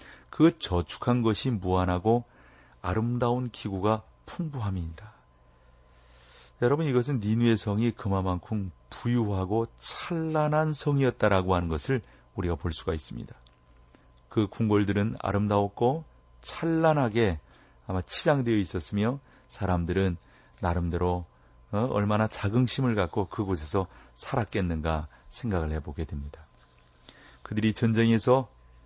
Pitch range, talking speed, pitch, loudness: 80-120 Hz, 270 characters per minute, 100 Hz, -28 LUFS